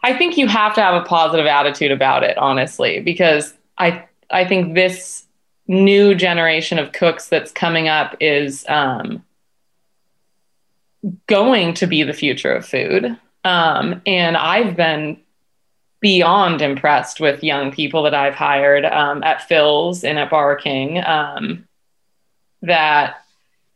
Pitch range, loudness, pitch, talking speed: 150-185 Hz, -15 LUFS, 165 Hz, 135 wpm